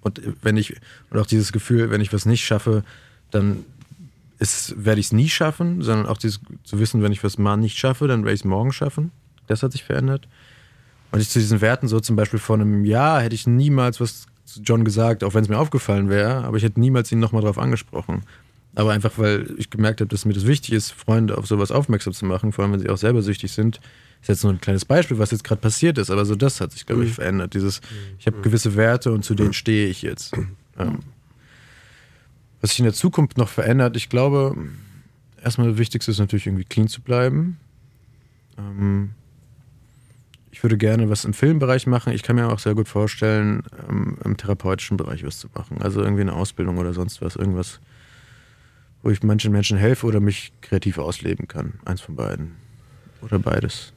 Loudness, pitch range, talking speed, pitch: -21 LUFS, 105-125 Hz, 215 wpm, 110 Hz